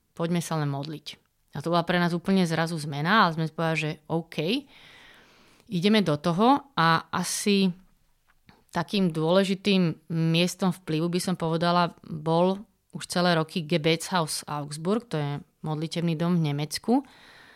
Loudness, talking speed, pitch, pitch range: -26 LUFS, 140 wpm, 170 Hz, 160-190 Hz